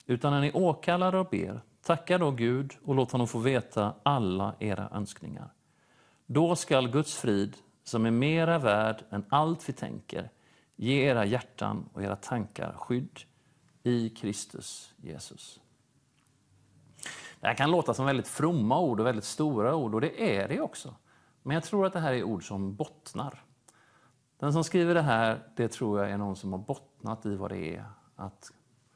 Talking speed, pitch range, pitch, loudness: 175 wpm, 105-150 Hz, 125 Hz, -30 LUFS